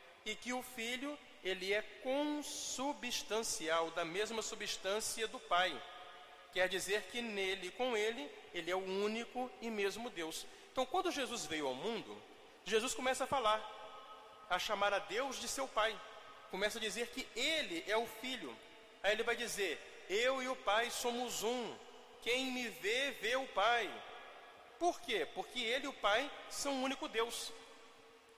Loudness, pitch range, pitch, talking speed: -38 LUFS, 210-260 Hz, 230 Hz, 165 wpm